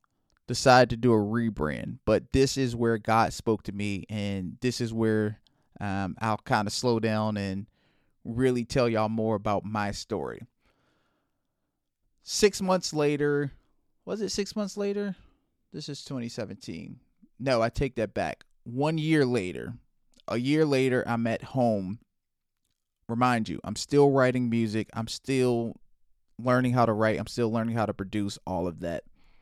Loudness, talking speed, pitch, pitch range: -27 LUFS, 155 wpm, 115 Hz, 105-130 Hz